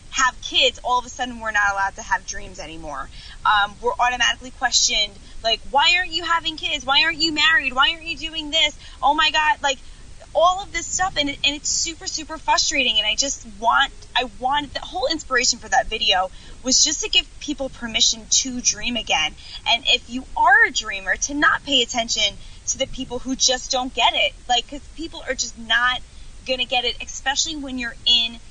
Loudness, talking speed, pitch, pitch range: -19 LUFS, 210 wpm, 265 Hz, 240-315 Hz